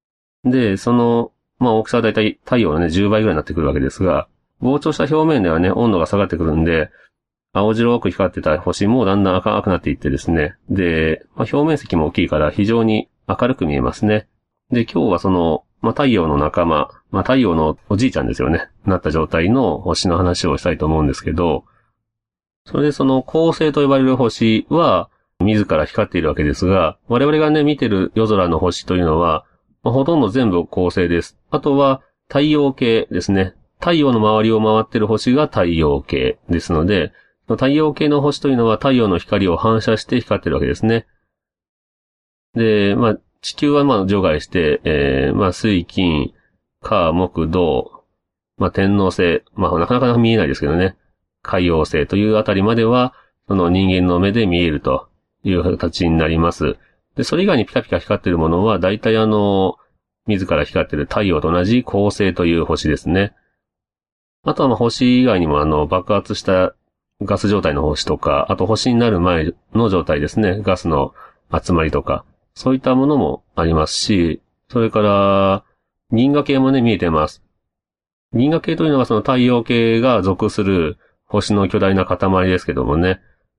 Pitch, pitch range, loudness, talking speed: 100 Hz, 85-115 Hz, -17 LUFS, 340 characters per minute